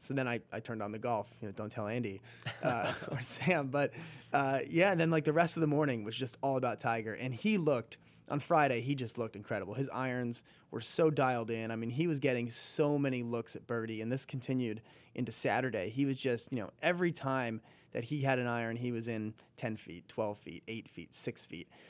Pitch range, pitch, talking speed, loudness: 115-145 Hz, 125 Hz, 235 wpm, -35 LUFS